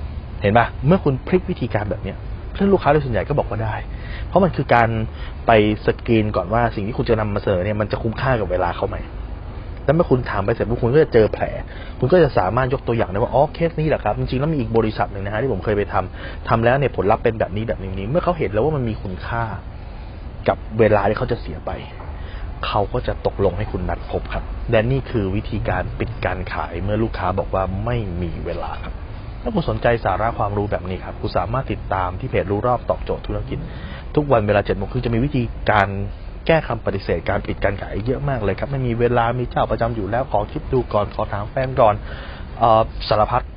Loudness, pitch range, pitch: -20 LUFS, 95-120 Hz, 105 Hz